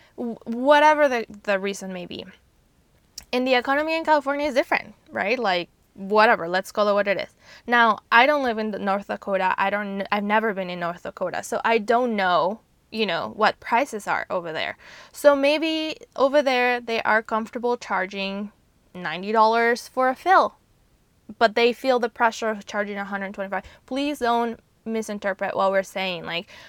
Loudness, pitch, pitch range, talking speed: -22 LUFS, 225 Hz, 200-250 Hz, 175 wpm